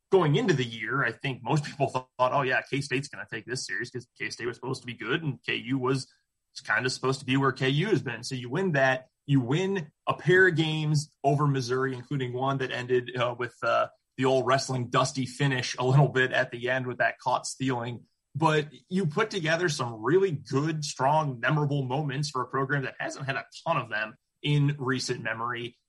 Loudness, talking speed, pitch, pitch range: -28 LUFS, 225 wpm, 135 Hz, 125-145 Hz